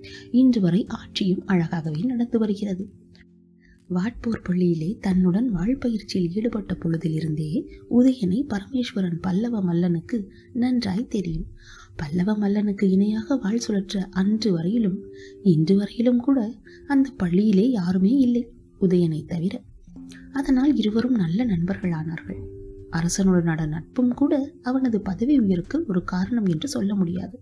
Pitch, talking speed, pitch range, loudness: 195 Hz, 110 wpm, 175-235 Hz, -23 LUFS